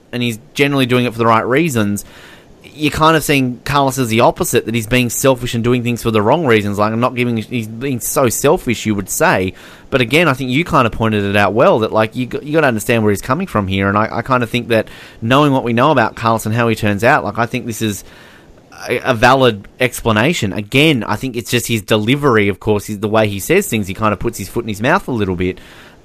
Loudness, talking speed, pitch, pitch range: -15 LUFS, 265 wpm, 115 Hz, 105-130 Hz